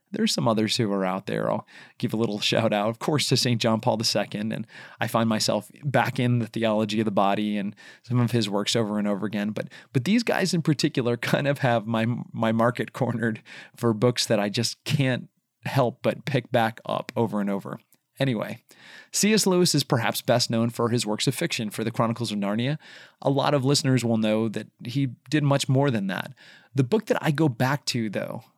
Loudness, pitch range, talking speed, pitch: -25 LUFS, 110-140 Hz, 220 wpm, 120 Hz